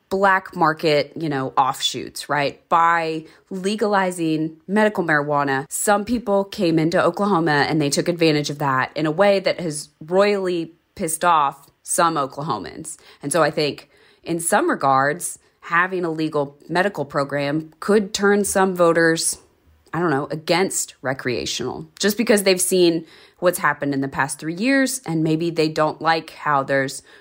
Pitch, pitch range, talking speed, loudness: 165 Hz, 150-190 Hz, 155 wpm, -20 LUFS